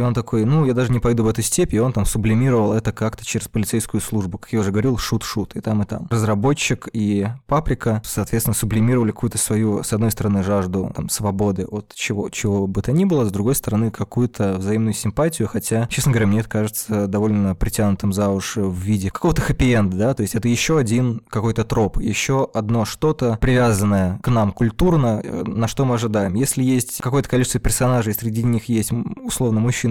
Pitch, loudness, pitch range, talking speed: 110 Hz, -20 LUFS, 105-125 Hz, 195 wpm